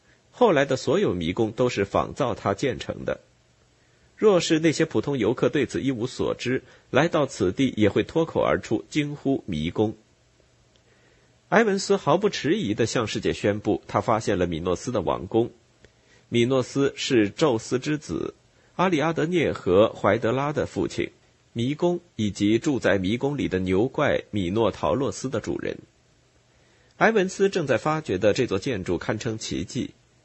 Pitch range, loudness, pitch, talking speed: 110-150 Hz, -24 LUFS, 125 Hz, 245 characters per minute